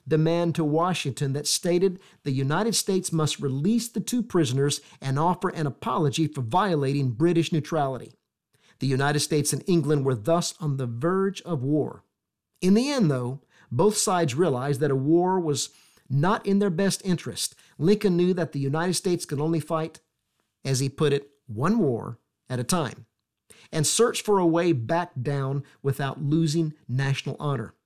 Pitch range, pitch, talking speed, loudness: 135-175 Hz, 155 Hz, 170 wpm, -25 LUFS